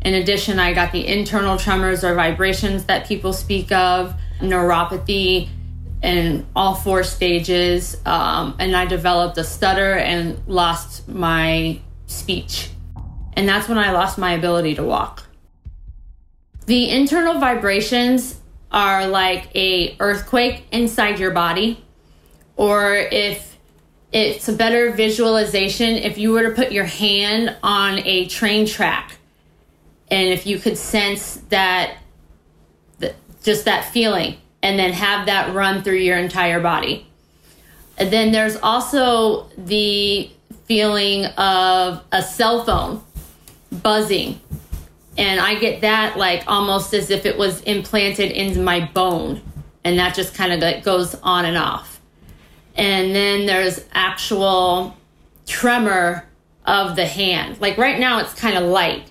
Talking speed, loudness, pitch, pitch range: 135 wpm, -18 LUFS, 190 Hz, 175-210 Hz